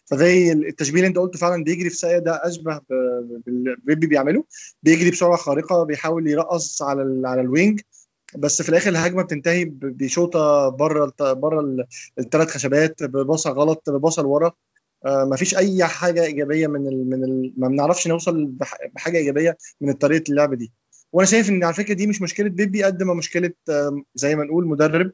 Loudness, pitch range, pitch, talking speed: -20 LUFS, 140-175 Hz, 160 Hz, 165 wpm